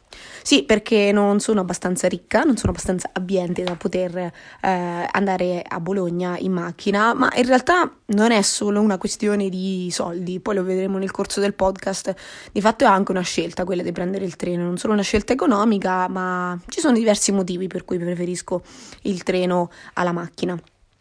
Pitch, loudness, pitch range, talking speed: 190 Hz, -21 LUFS, 180-210 Hz, 180 wpm